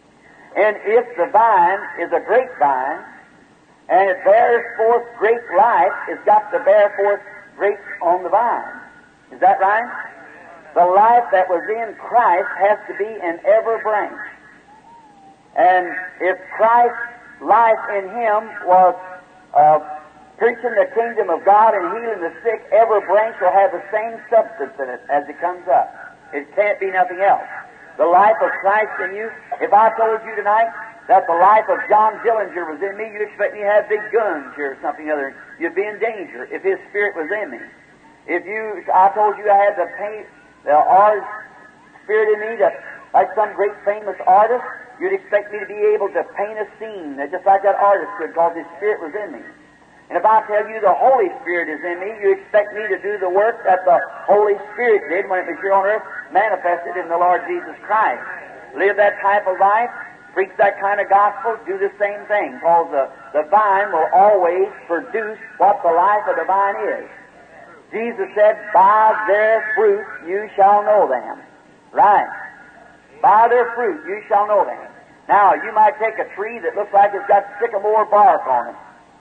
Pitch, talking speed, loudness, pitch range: 210 Hz, 190 wpm, -17 LUFS, 190-230 Hz